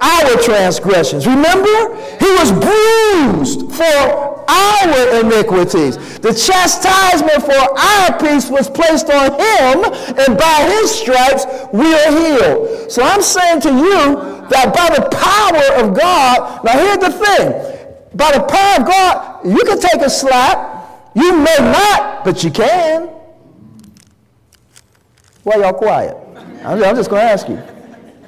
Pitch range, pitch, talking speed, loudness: 275-380 Hz, 320 Hz, 140 wpm, -11 LUFS